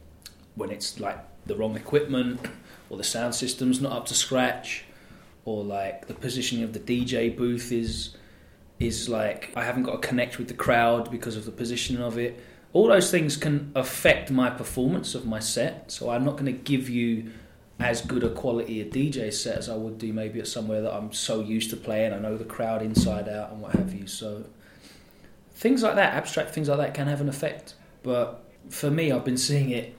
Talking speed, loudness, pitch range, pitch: 210 wpm, -27 LUFS, 110-130 Hz, 120 Hz